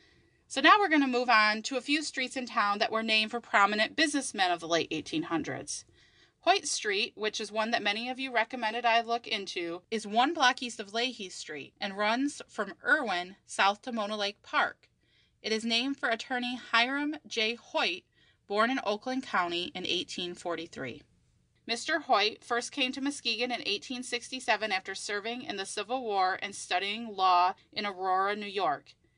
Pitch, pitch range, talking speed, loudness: 230 Hz, 200-260 Hz, 180 wpm, -30 LUFS